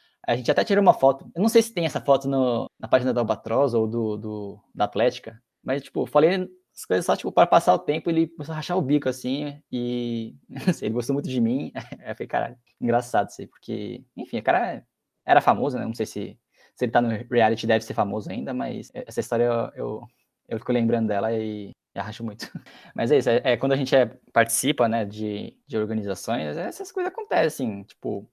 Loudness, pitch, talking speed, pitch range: -24 LUFS, 120 Hz, 220 wpm, 110-140 Hz